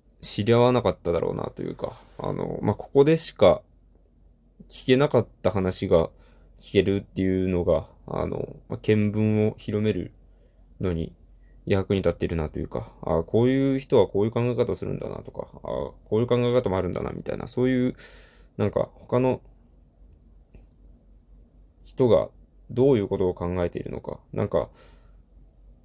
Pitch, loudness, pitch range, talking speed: 105 Hz, -25 LUFS, 90-125 Hz, 315 characters per minute